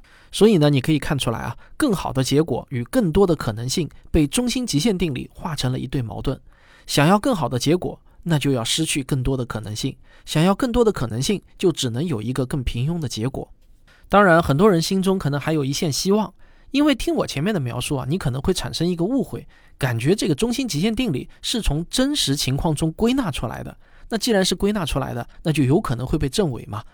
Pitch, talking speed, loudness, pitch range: 155 Hz, 335 characters per minute, -21 LUFS, 135-195 Hz